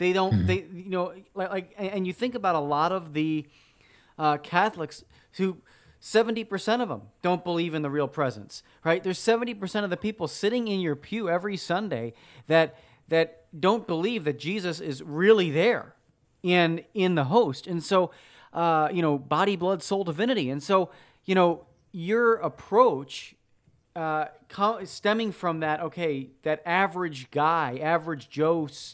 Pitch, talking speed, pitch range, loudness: 175 Hz, 160 wpm, 155-195 Hz, -26 LUFS